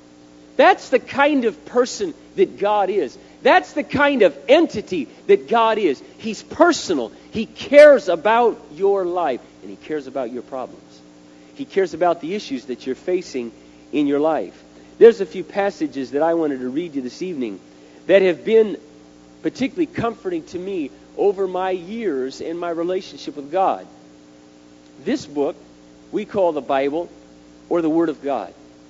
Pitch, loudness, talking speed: 170 Hz, -19 LUFS, 160 wpm